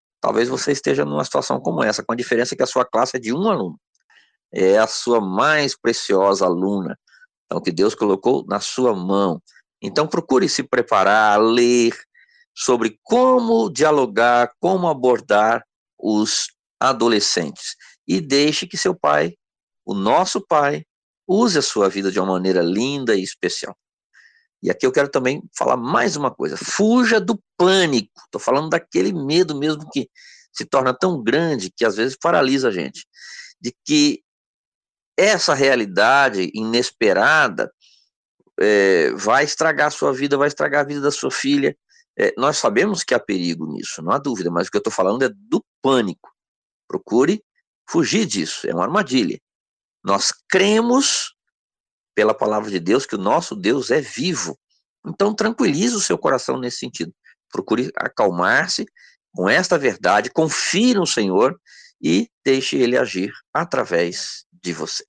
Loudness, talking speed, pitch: -19 LUFS, 155 wpm, 145 Hz